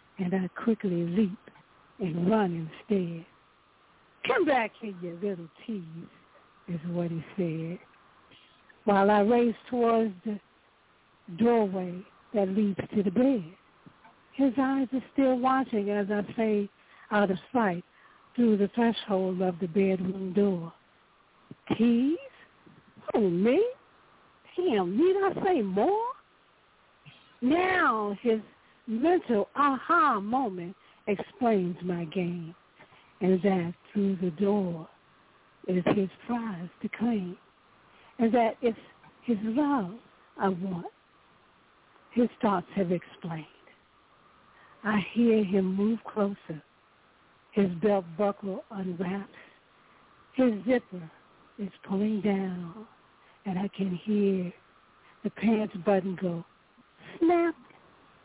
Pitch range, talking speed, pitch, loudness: 185-235 Hz, 110 wpm, 205 Hz, -28 LUFS